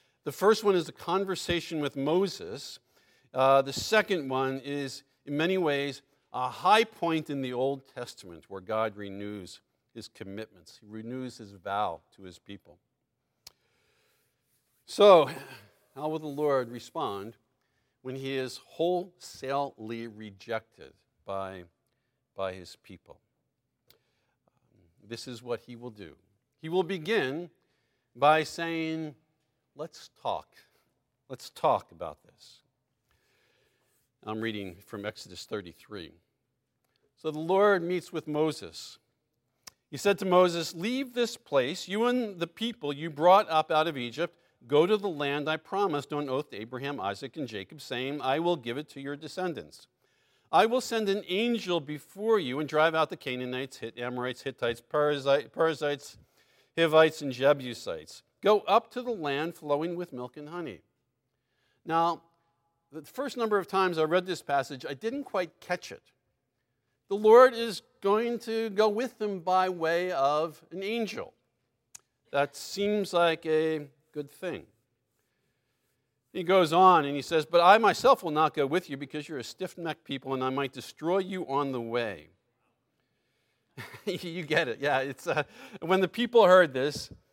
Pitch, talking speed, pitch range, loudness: 150 Hz, 150 wpm, 130-180 Hz, -28 LUFS